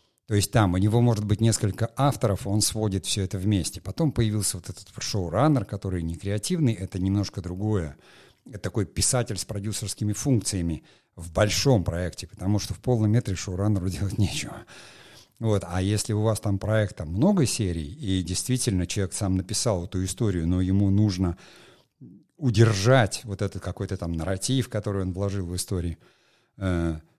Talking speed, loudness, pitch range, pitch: 160 wpm, -26 LUFS, 95-110 Hz, 100 Hz